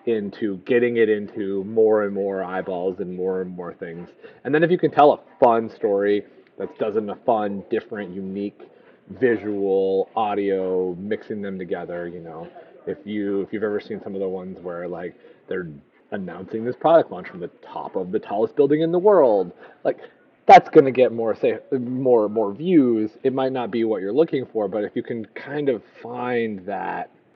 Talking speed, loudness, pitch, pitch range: 195 wpm, -21 LUFS, 105 Hz, 95-120 Hz